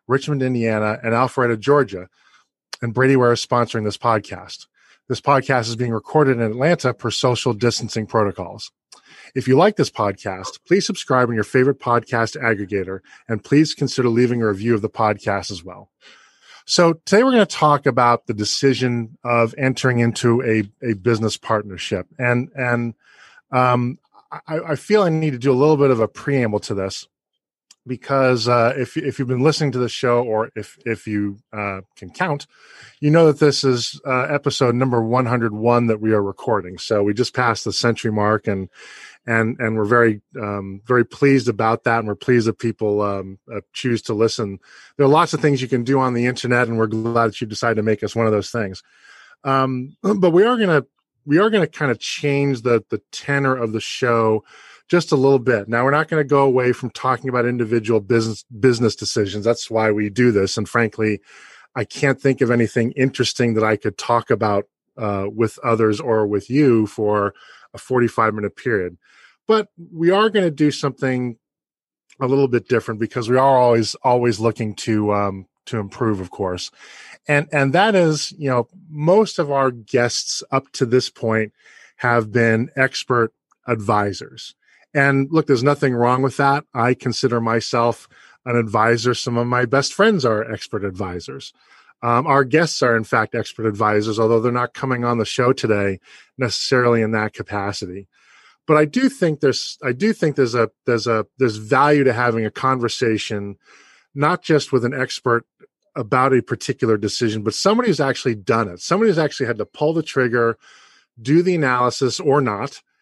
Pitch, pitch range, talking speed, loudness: 120 Hz, 110-135 Hz, 185 wpm, -19 LUFS